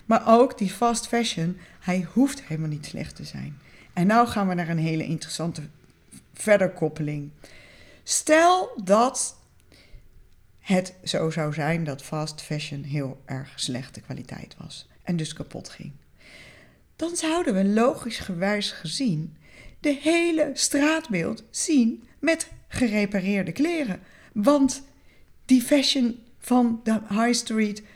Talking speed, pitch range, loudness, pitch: 130 wpm, 155-245 Hz, -24 LUFS, 200 Hz